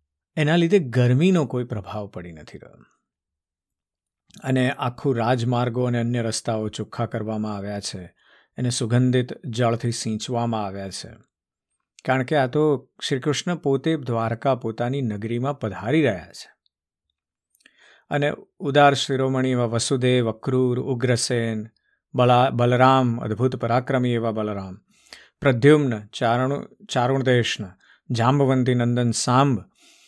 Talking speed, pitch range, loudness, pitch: 110 wpm, 110-130 Hz, -22 LUFS, 120 Hz